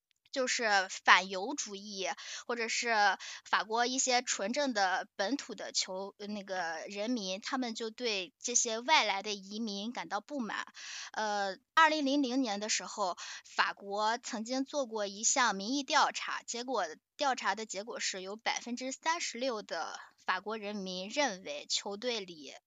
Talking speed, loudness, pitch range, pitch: 225 characters per minute, -33 LUFS, 200-260 Hz, 220 Hz